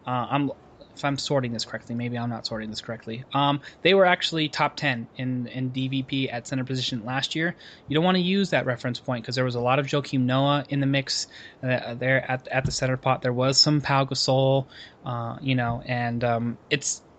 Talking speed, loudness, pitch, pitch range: 225 wpm, -25 LUFS, 130 Hz, 120-140 Hz